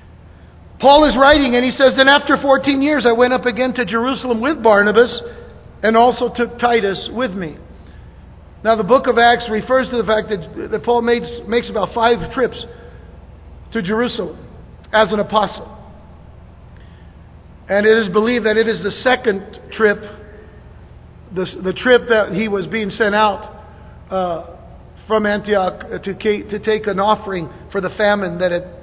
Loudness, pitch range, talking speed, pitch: -16 LUFS, 195-240 Hz, 160 wpm, 220 Hz